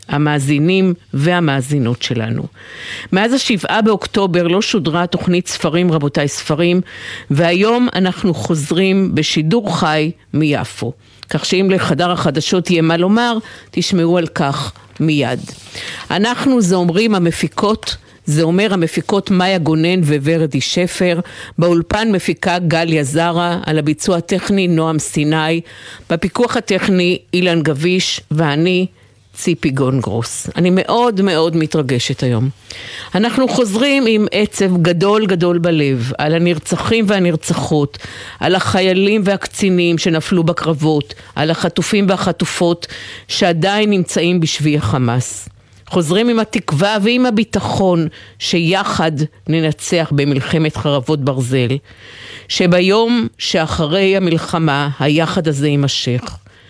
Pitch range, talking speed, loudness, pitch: 150-190 Hz, 105 wpm, -15 LUFS, 170 Hz